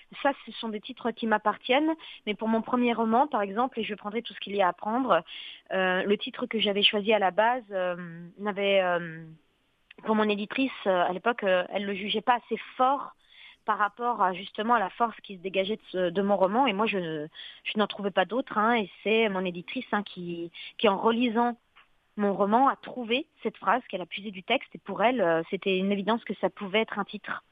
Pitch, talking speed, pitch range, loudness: 210 Hz, 235 wpm, 190-235 Hz, -28 LUFS